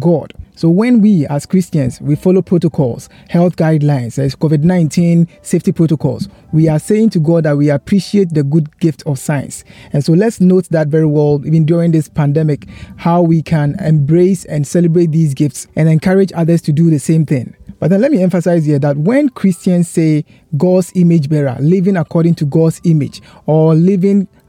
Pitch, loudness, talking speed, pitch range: 165 Hz, -12 LUFS, 185 wpm, 150-180 Hz